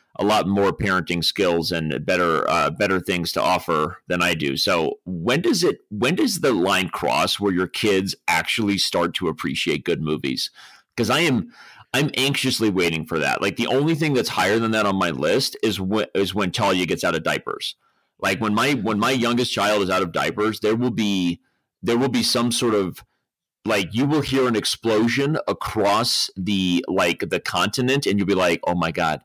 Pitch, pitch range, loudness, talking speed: 105 Hz, 95-125 Hz, -21 LUFS, 205 wpm